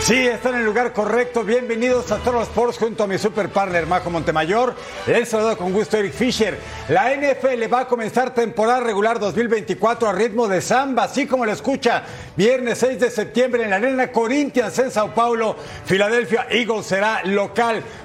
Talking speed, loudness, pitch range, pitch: 185 wpm, -19 LUFS, 210-245 Hz, 230 Hz